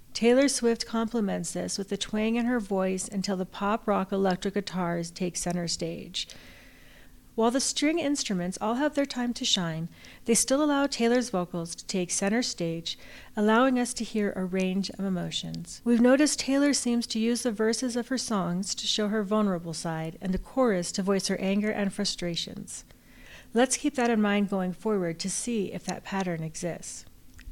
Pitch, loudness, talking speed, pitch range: 205 Hz, -28 LUFS, 180 wpm, 180-235 Hz